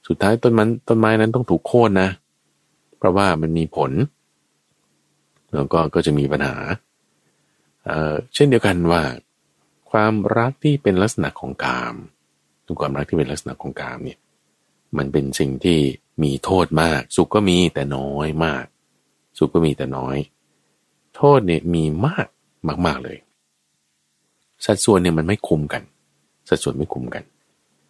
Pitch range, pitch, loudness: 75-100 Hz, 80 Hz, -19 LUFS